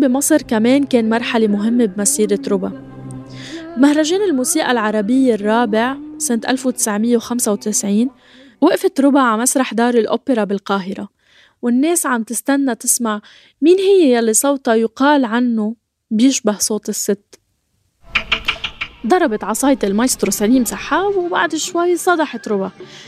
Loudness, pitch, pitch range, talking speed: -16 LUFS, 240 Hz, 215-275 Hz, 110 wpm